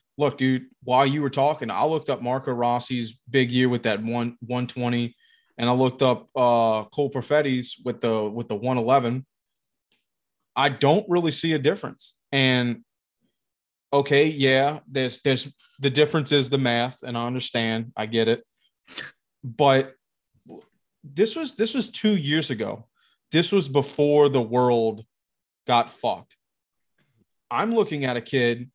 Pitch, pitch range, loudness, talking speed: 130 Hz, 120-145 Hz, -23 LUFS, 150 wpm